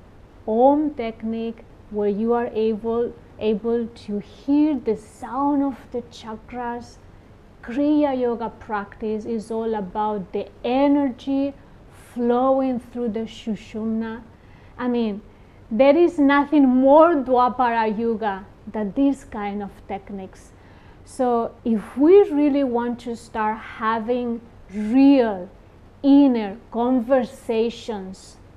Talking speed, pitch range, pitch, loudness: 105 wpm, 215-260 Hz, 230 Hz, -21 LUFS